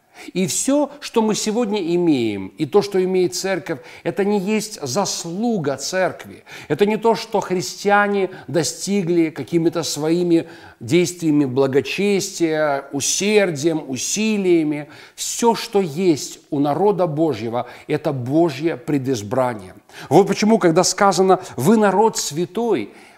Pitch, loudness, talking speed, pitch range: 175 Hz, -19 LUFS, 115 wpm, 150-200 Hz